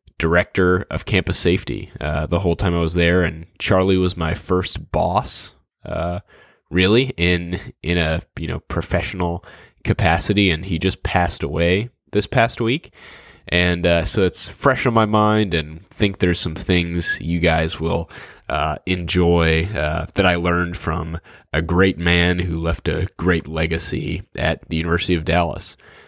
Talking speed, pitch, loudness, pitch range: 160 wpm, 85 Hz, -19 LUFS, 85-95 Hz